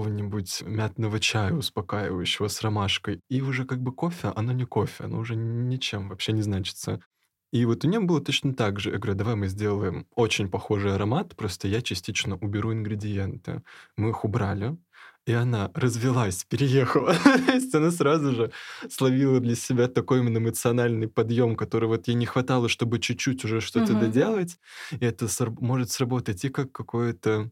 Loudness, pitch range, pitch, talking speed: -26 LUFS, 105-130 Hz, 115 Hz, 165 wpm